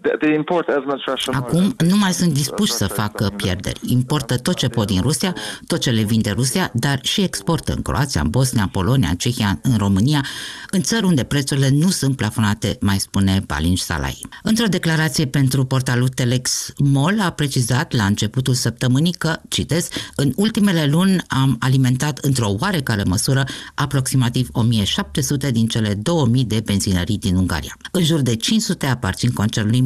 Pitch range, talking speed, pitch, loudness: 110-155 Hz, 160 wpm, 130 Hz, -19 LUFS